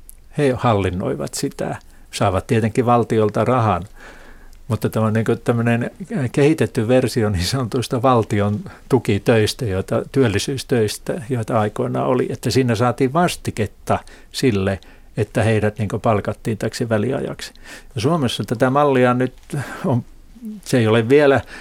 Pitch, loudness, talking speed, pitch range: 120 Hz, -19 LUFS, 120 wpm, 110-130 Hz